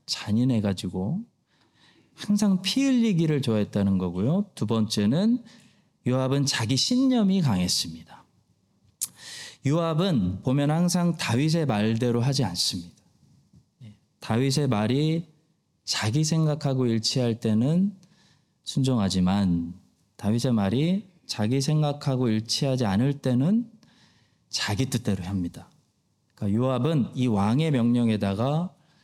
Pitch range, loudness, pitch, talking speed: 110-165 Hz, -25 LUFS, 130 Hz, 250 characters per minute